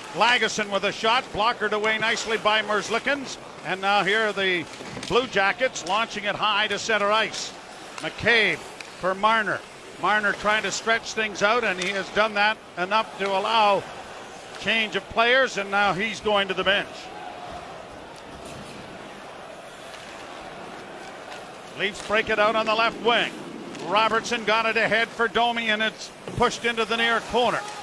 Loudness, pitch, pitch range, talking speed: -23 LUFS, 215 Hz, 200-225 Hz, 150 wpm